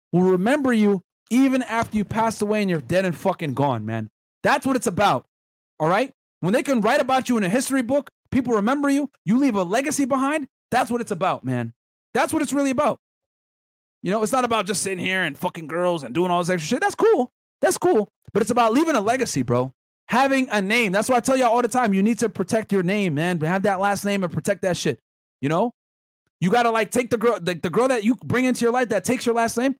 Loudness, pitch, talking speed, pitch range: -22 LUFS, 220 Hz, 255 wpm, 185-250 Hz